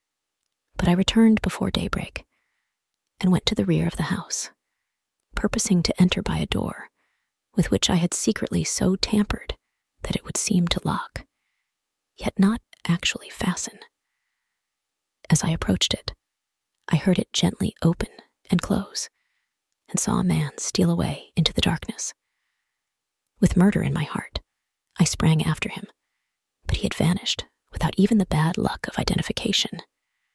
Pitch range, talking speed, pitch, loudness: 170-205 Hz, 150 wpm, 185 Hz, -23 LUFS